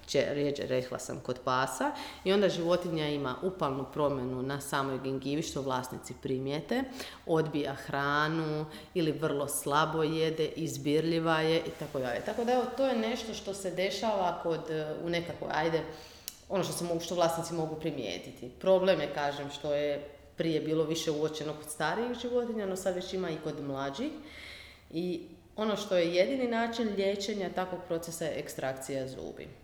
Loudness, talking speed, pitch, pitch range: -32 LUFS, 155 wpm, 160 Hz, 145-190 Hz